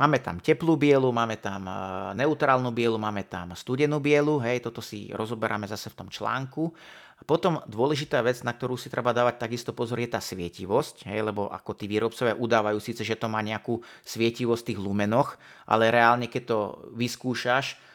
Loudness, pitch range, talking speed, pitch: -27 LUFS, 105-125 Hz, 180 wpm, 115 Hz